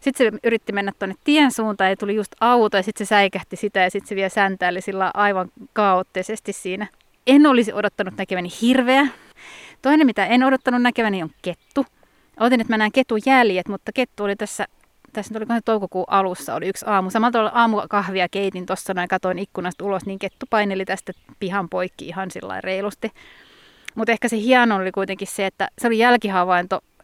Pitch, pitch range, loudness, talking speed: 205 Hz, 190-230 Hz, -20 LUFS, 185 wpm